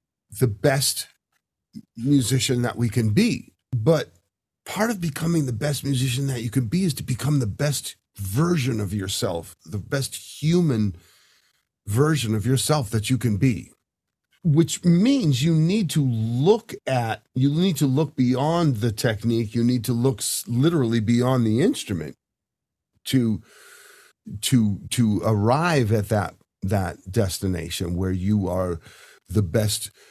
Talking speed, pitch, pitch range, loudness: 140 wpm, 125 Hz, 105-145 Hz, -23 LUFS